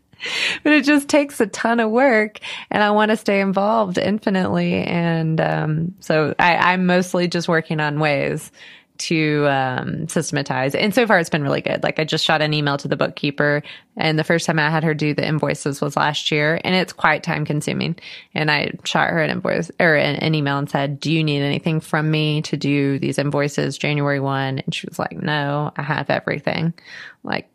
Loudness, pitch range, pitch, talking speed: -19 LUFS, 150-185 Hz, 160 Hz, 205 wpm